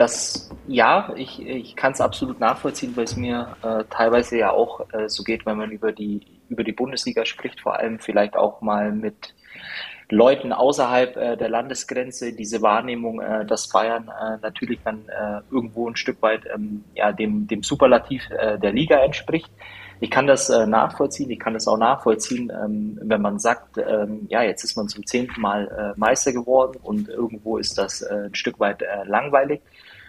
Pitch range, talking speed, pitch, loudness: 105-120 Hz, 185 wpm, 110 Hz, -22 LUFS